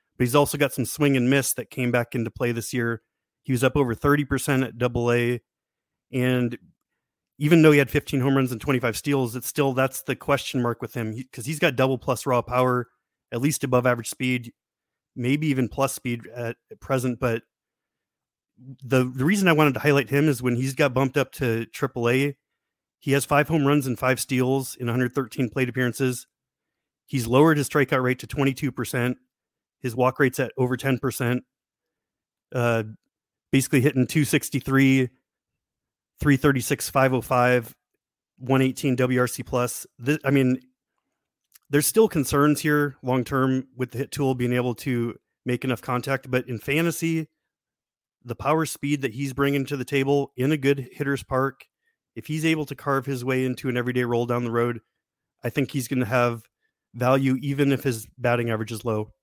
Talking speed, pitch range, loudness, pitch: 185 wpm, 125-140 Hz, -24 LUFS, 130 Hz